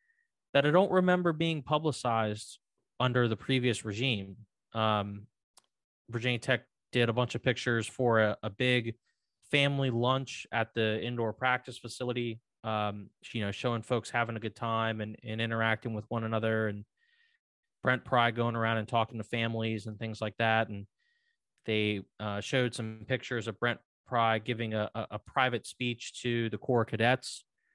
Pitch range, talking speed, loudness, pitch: 110-125 Hz, 165 wpm, -31 LUFS, 115 Hz